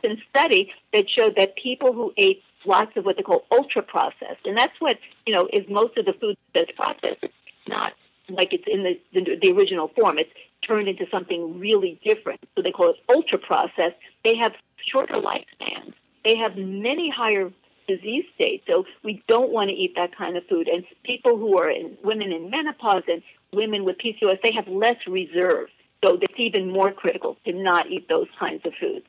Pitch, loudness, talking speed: 250 Hz, -22 LUFS, 200 wpm